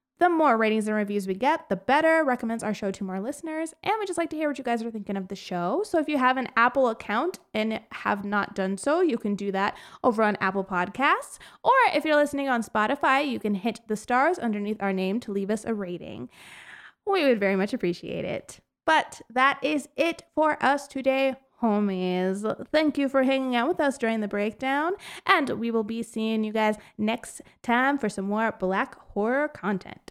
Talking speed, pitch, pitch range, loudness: 215 wpm, 230 Hz, 205-290 Hz, -26 LUFS